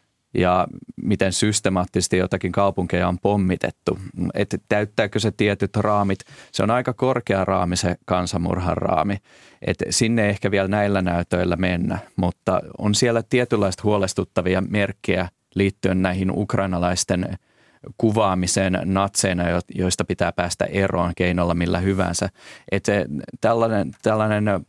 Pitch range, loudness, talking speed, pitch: 90-105 Hz, -22 LUFS, 120 wpm, 95 Hz